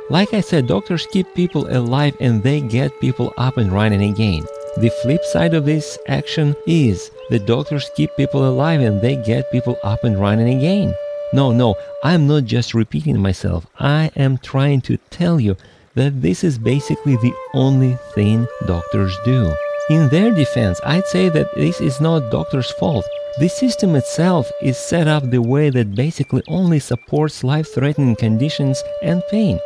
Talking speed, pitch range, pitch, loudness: 170 wpm, 120-160 Hz, 140 Hz, -17 LUFS